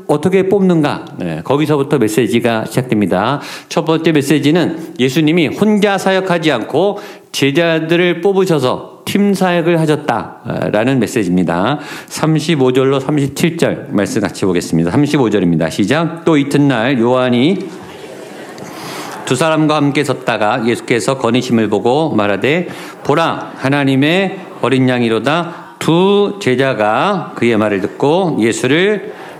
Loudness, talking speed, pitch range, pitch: -14 LUFS, 275 characters per minute, 120-170 Hz, 145 Hz